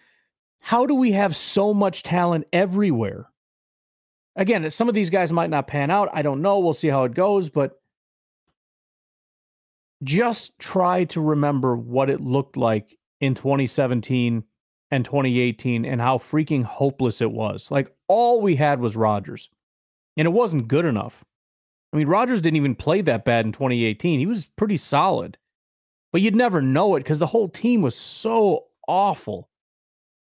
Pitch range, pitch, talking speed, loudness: 120-190 Hz, 145 Hz, 160 wpm, -21 LUFS